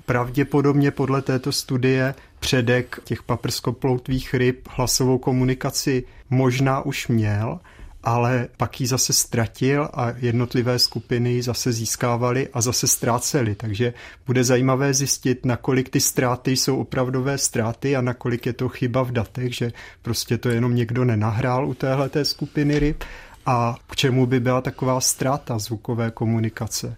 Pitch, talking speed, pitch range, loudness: 125 Hz, 140 wpm, 120-135 Hz, -22 LUFS